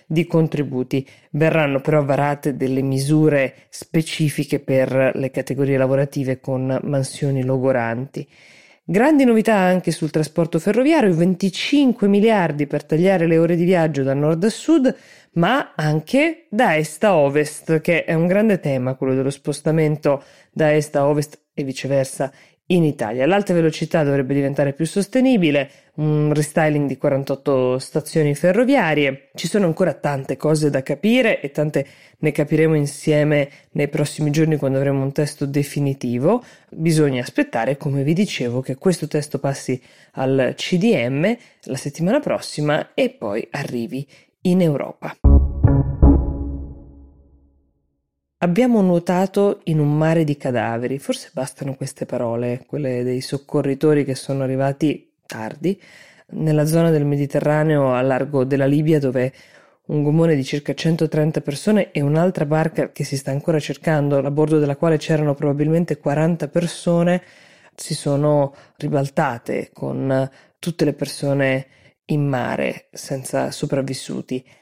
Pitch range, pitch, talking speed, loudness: 135-165 Hz, 150 Hz, 135 wpm, -19 LUFS